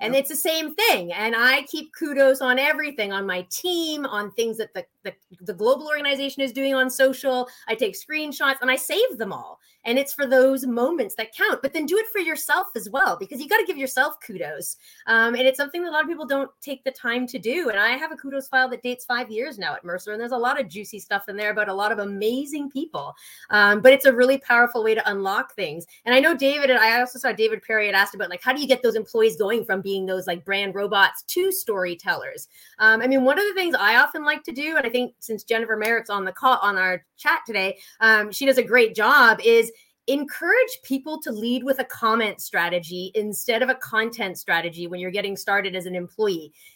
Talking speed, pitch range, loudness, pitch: 245 wpm, 210-290 Hz, -21 LUFS, 255 Hz